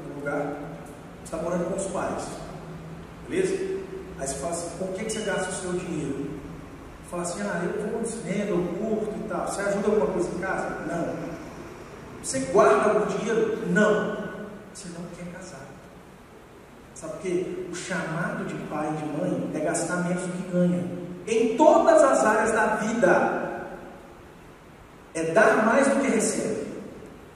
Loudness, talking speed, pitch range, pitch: -25 LUFS, 160 wpm, 175-215 Hz, 190 Hz